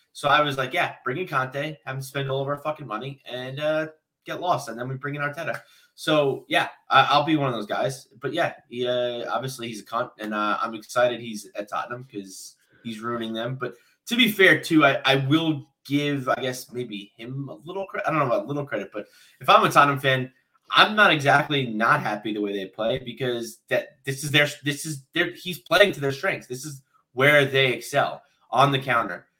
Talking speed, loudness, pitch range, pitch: 225 wpm, -23 LUFS, 120-150 Hz, 135 Hz